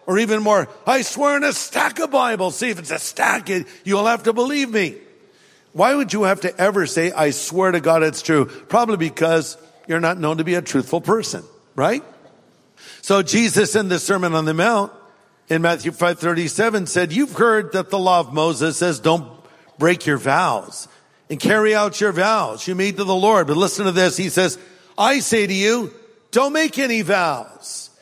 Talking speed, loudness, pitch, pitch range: 200 wpm, -18 LUFS, 190 Hz, 170-220 Hz